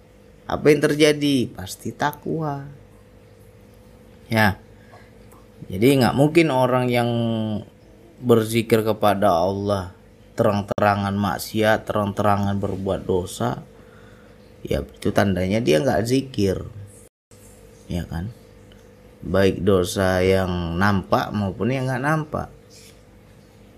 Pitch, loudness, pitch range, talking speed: 105 Hz, -21 LUFS, 100-115 Hz, 90 wpm